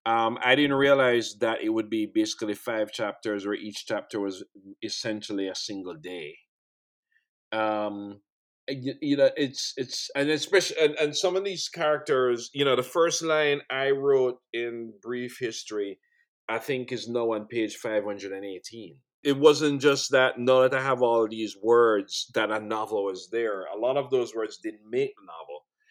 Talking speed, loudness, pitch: 185 wpm, -26 LUFS, 135 Hz